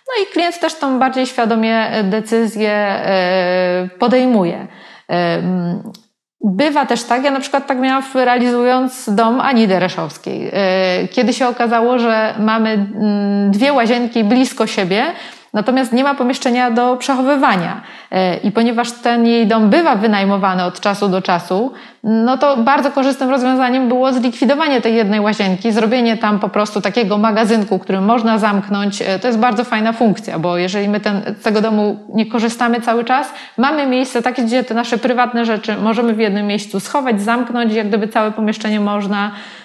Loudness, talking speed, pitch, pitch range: -15 LUFS, 150 wpm, 230 Hz, 205-250 Hz